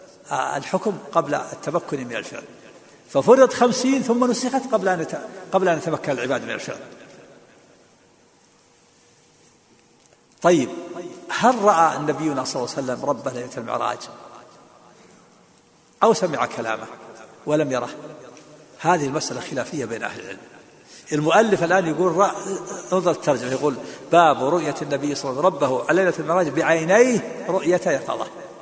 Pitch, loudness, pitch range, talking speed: 165 Hz, -21 LUFS, 150-200 Hz, 125 wpm